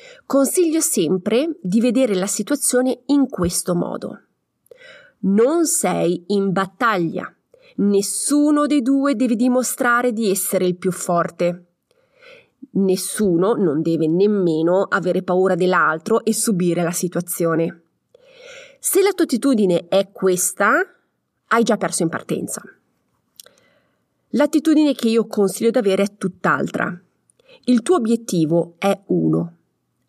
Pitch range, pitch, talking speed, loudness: 180-285 Hz, 215 Hz, 115 wpm, -19 LUFS